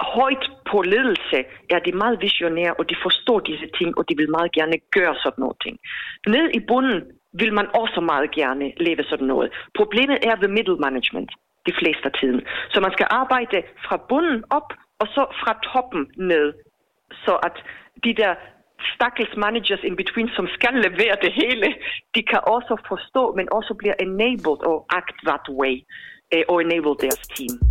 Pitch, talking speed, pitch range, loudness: 195 Hz, 175 wpm, 165-230 Hz, -21 LUFS